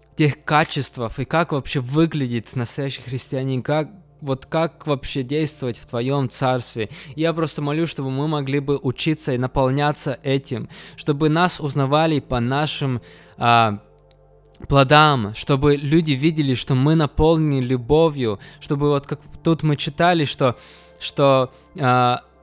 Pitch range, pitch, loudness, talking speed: 125-150 Hz, 140 Hz, -20 LUFS, 135 wpm